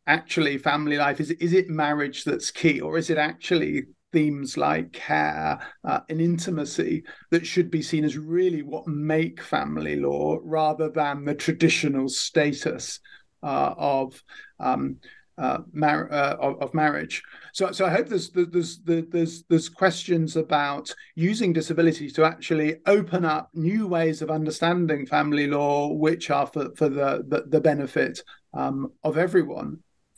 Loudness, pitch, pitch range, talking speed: -24 LUFS, 155 Hz, 145-170 Hz, 155 wpm